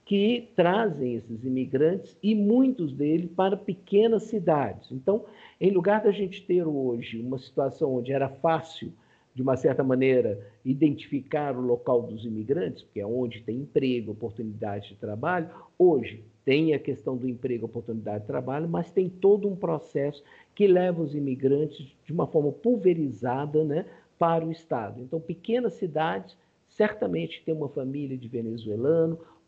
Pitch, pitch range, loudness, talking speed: 150 Hz, 125-180 Hz, -27 LUFS, 150 wpm